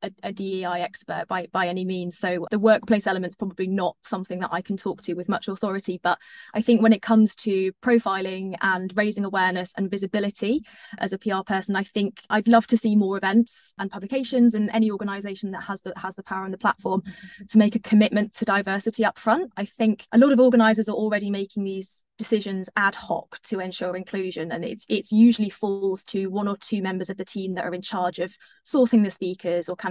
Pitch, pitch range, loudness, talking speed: 200 Hz, 190-220 Hz, -23 LUFS, 220 wpm